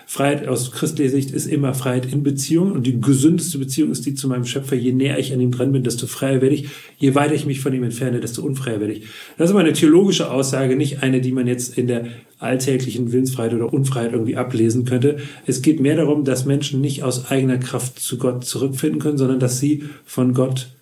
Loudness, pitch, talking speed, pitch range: -19 LUFS, 135 Hz, 230 wpm, 125-145 Hz